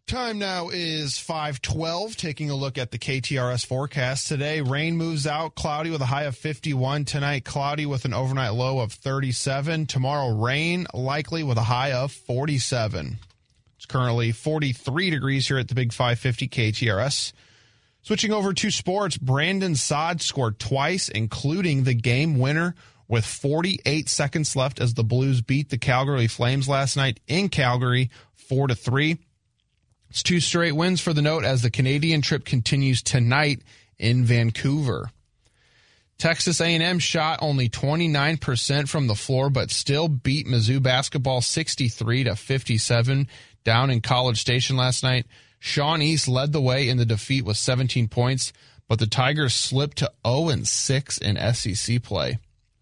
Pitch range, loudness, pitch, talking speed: 120-150 Hz, -23 LUFS, 135 Hz, 150 wpm